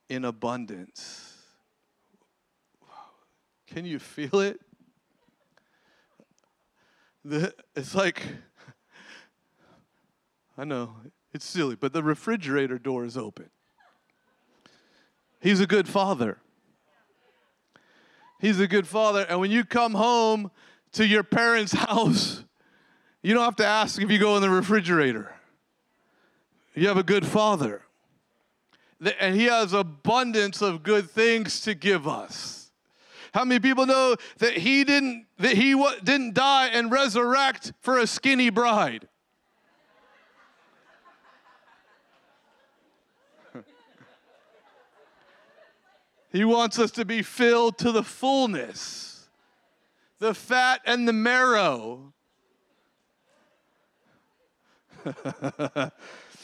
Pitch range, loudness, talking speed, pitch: 185-240 Hz, -24 LUFS, 100 wpm, 215 Hz